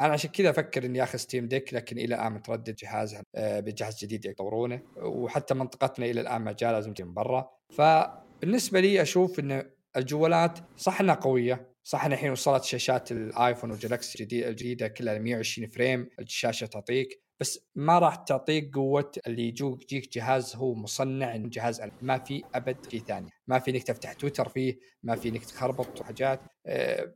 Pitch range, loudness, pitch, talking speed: 115-140 Hz, -29 LUFS, 130 Hz, 170 wpm